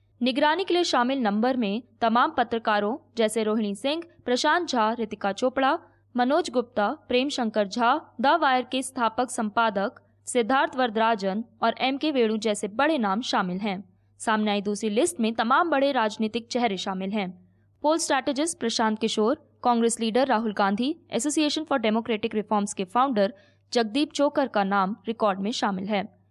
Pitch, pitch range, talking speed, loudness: 230 Hz, 215-270 Hz, 155 wpm, -25 LUFS